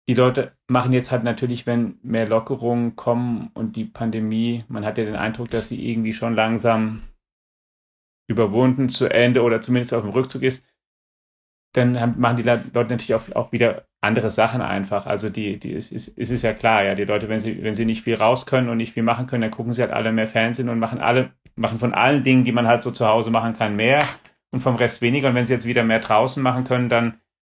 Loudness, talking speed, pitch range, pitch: -21 LUFS, 230 wpm, 110-125 Hz, 115 Hz